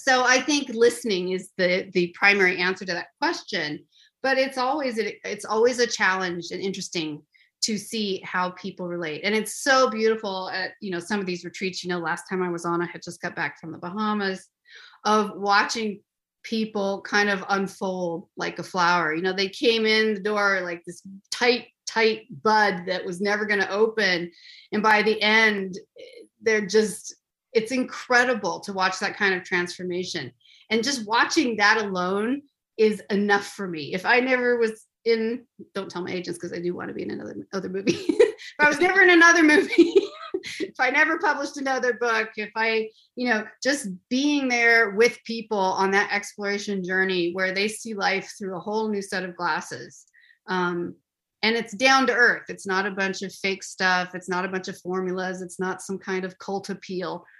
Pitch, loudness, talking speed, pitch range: 205 Hz, -23 LUFS, 190 wpm, 185-235 Hz